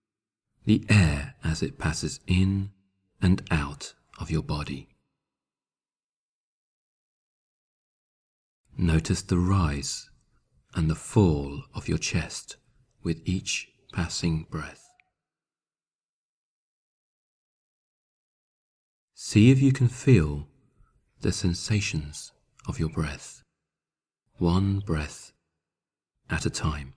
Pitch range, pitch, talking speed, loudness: 75-100 Hz, 85 Hz, 85 wpm, -26 LUFS